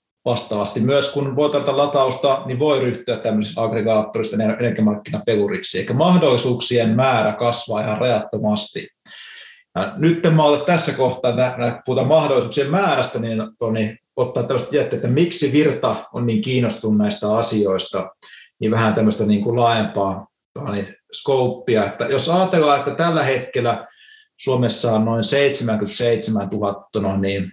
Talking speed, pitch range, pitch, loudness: 125 wpm, 110-140 Hz, 120 Hz, -19 LUFS